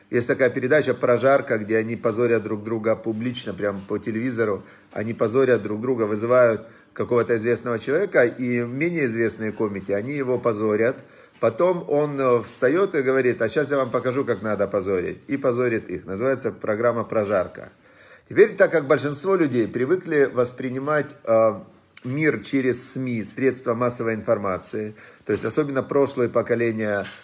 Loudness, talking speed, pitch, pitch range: -22 LUFS, 145 wpm, 120 Hz, 110-135 Hz